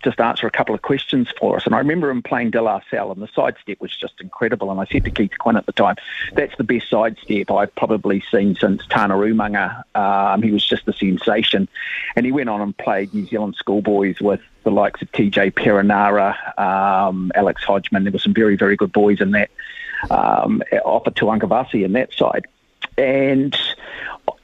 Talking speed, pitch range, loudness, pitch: 200 wpm, 100-110 Hz, -18 LUFS, 105 Hz